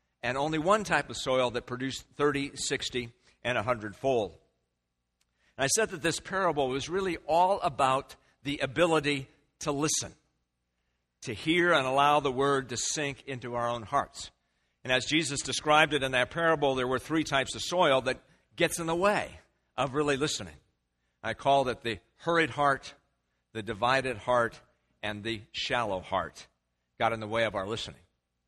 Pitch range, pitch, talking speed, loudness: 110-150 Hz, 130 Hz, 170 wpm, -29 LUFS